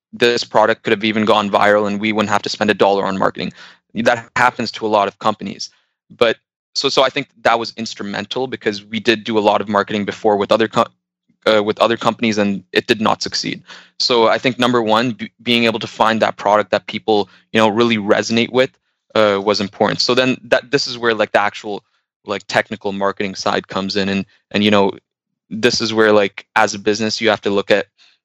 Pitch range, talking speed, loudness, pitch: 105-115 Hz, 225 wpm, -16 LUFS, 110 Hz